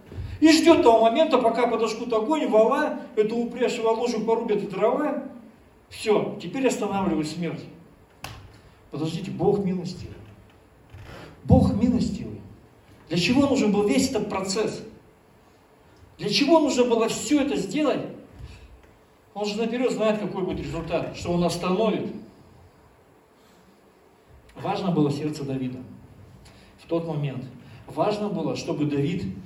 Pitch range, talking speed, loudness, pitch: 155-230 Hz, 120 wpm, -24 LUFS, 200 Hz